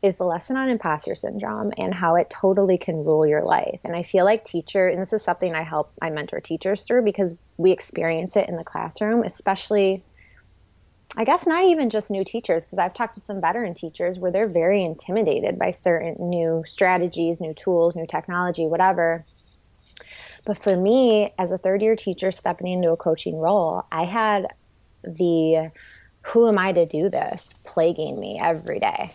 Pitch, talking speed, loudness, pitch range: 180 Hz, 185 wpm, -22 LUFS, 165-205 Hz